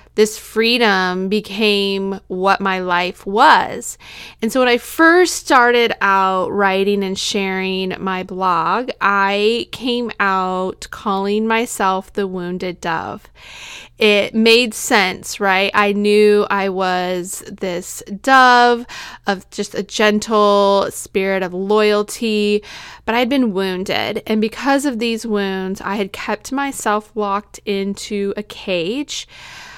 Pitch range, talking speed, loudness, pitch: 190-225 Hz, 125 wpm, -16 LUFS, 205 Hz